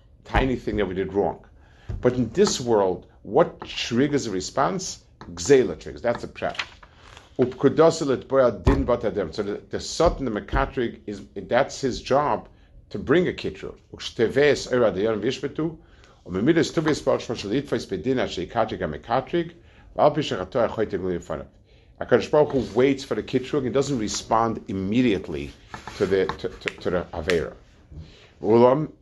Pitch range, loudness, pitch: 100-140 Hz, -24 LUFS, 125 Hz